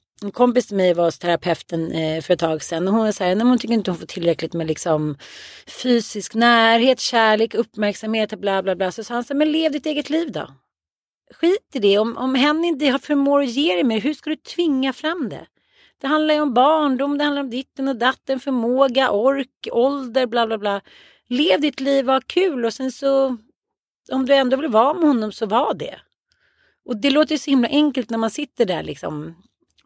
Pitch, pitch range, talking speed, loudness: 250 Hz, 215-280 Hz, 210 wpm, -19 LUFS